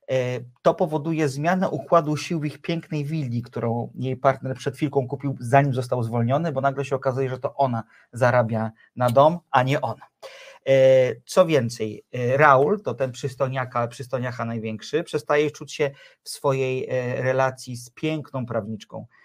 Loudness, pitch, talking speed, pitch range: -23 LUFS, 135 Hz, 150 wpm, 125-150 Hz